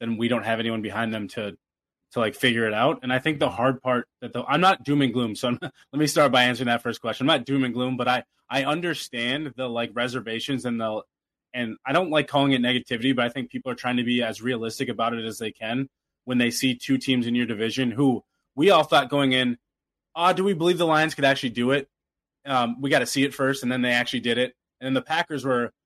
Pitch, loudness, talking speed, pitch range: 125 Hz, -24 LUFS, 265 wpm, 120-135 Hz